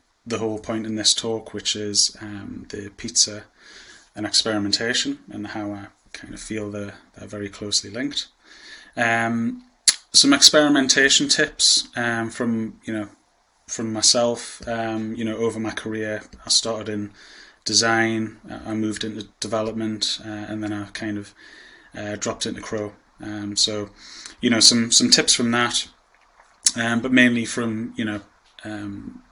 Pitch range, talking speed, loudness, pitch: 105-115 Hz, 150 wpm, -20 LUFS, 110 Hz